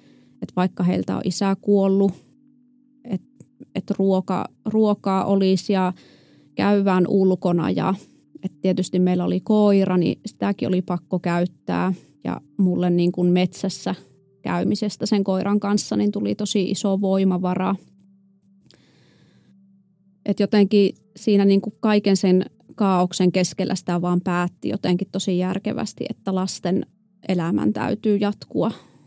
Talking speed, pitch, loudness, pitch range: 120 wpm, 190 Hz, -21 LUFS, 180-200 Hz